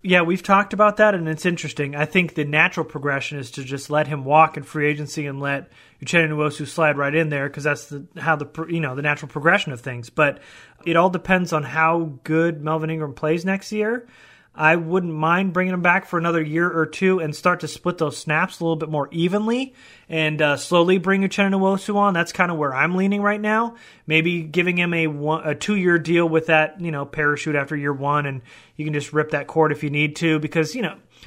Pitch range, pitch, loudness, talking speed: 150-180 Hz, 160 Hz, -21 LUFS, 230 wpm